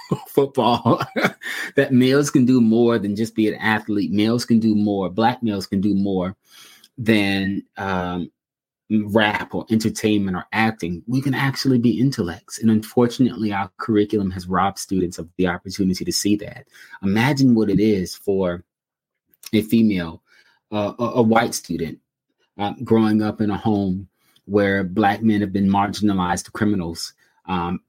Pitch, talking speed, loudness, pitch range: 105 Hz, 155 wpm, -20 LUFS, 95-115 Hz